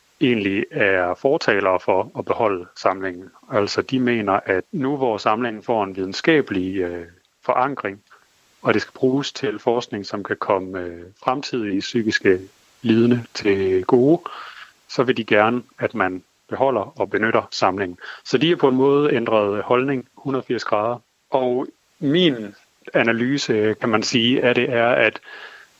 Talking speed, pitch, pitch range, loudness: 150 wpm, 115 Hz, 95-125 Hz, -20 LUFS